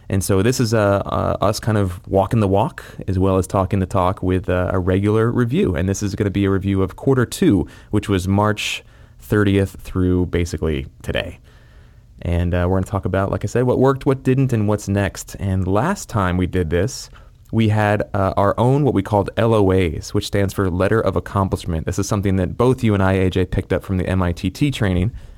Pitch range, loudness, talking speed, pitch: 95-105 Hz, -19 LUFS, 220 wpm, 100 Hz